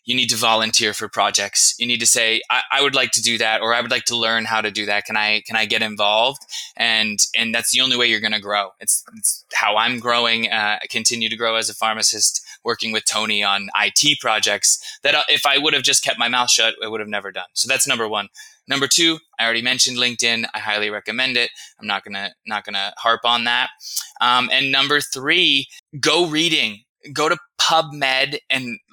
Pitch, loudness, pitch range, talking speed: 115 Hz, -17 LUFS, 110-130 Hz, 230 wpm